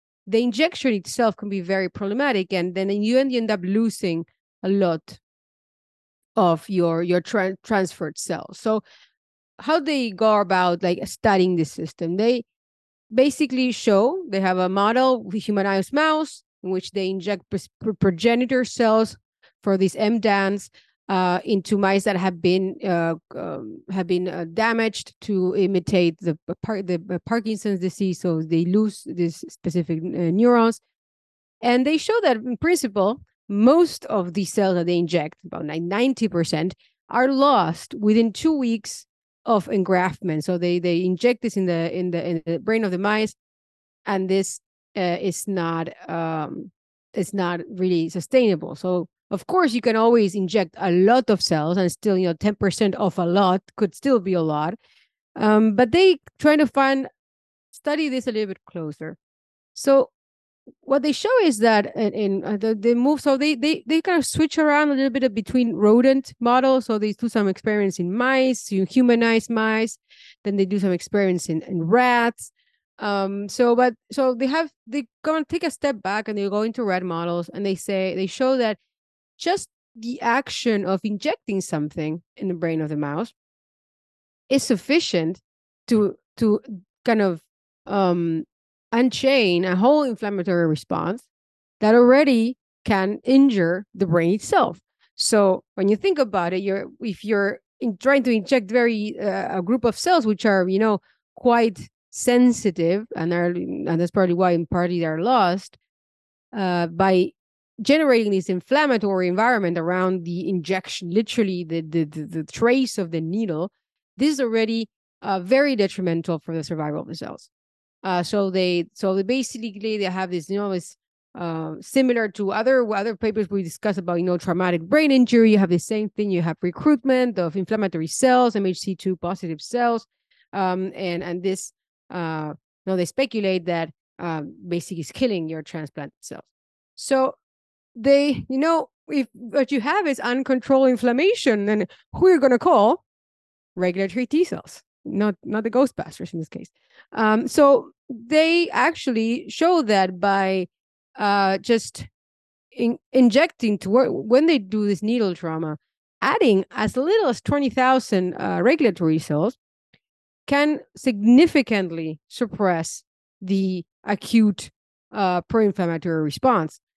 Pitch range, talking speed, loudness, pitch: 180-245 Hz, 160 wpm, -21 LUFS, 205 Hz